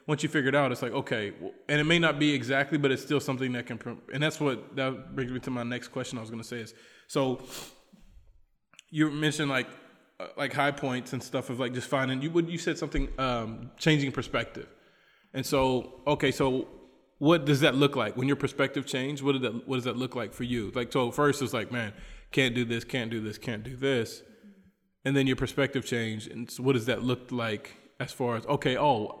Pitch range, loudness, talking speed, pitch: 125-145 Hz, -29 LUFS, 230 wpm, 130 Hz